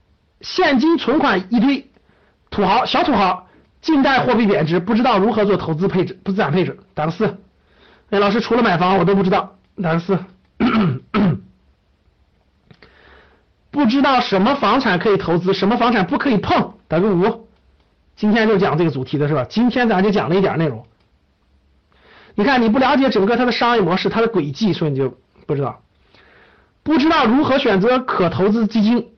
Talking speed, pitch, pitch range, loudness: 270 characters per minute, 200 Hz, 180-235 Hz, -17 LUFS